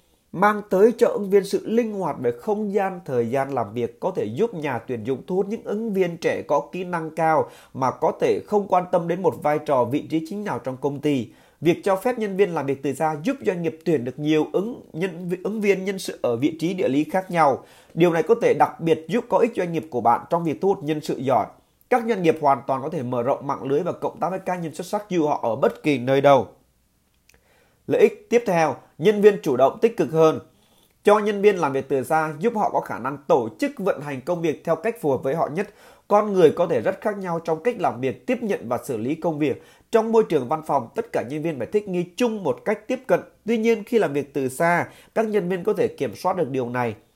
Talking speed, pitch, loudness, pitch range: 265 wpm, 175 Hz, -23 LUFS, 150-210 Hz